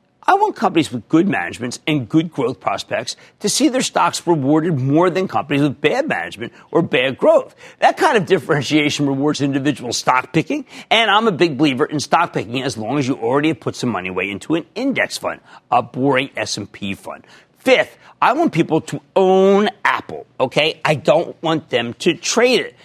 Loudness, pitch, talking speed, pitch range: -17 LUFS, 155 Hz, 190 wpm, 135-175 Hz